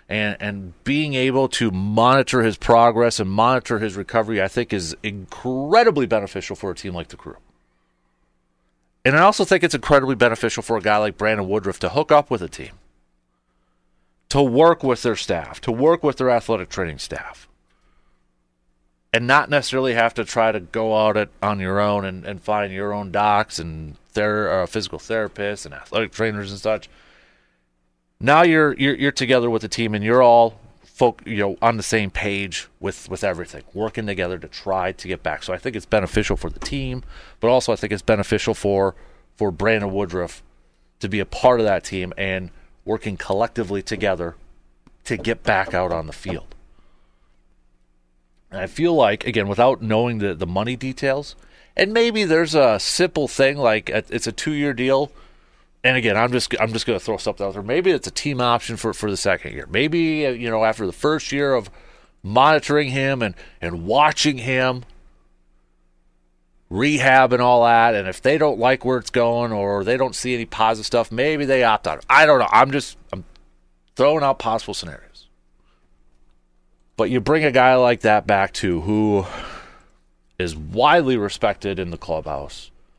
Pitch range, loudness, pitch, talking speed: 85-125 Hz, -19 LUFS, 105 Hz, 185 wpm